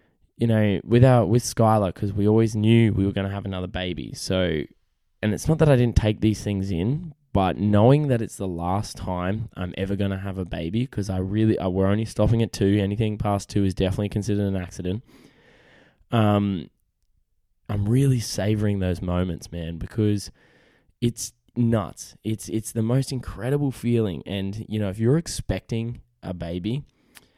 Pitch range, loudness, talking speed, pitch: 95-115 Hz, -24 LUFS, 180 wpm, 105 Hz